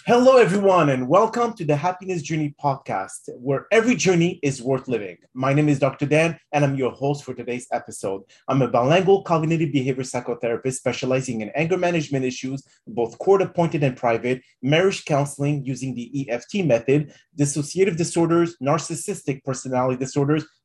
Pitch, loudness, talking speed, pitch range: 145 Hz, -22 LUFS, 155 wpm, 130-170 Hz